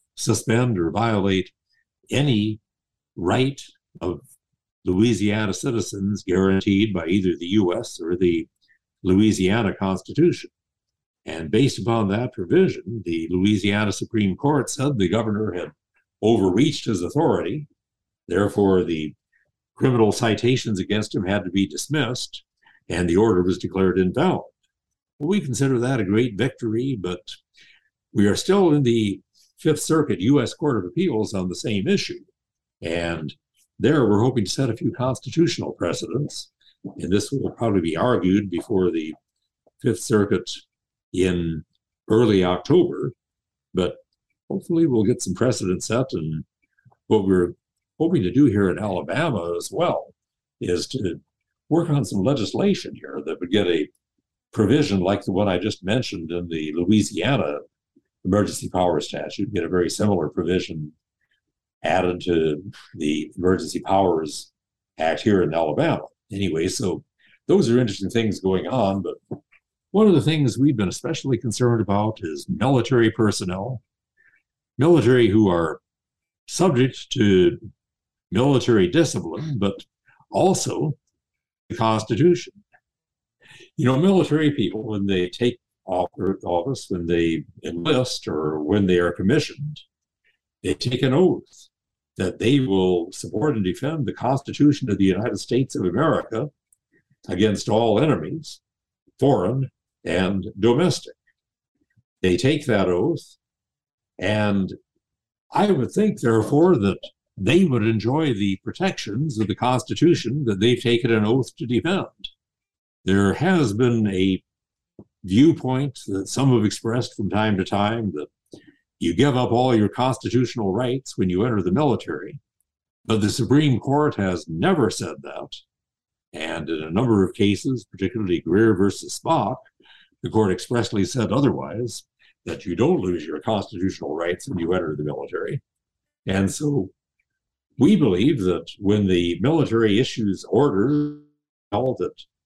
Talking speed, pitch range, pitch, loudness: 135 wpm, 95-130 Hz, 110 Hz, -22 LUFS